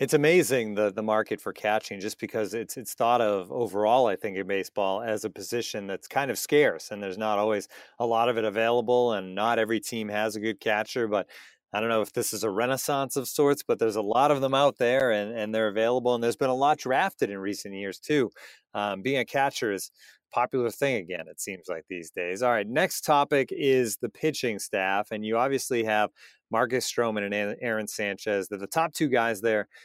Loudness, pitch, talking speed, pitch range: -27 LUFS, 115 Hz, 225 wpm, 105-130 Hz